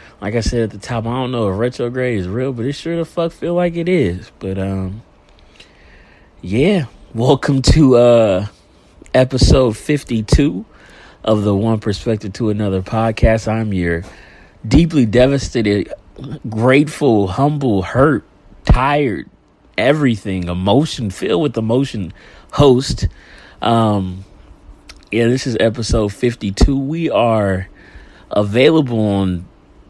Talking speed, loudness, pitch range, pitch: 125 wpm, -16 LUFS, 100-130 Hz, 115 Hz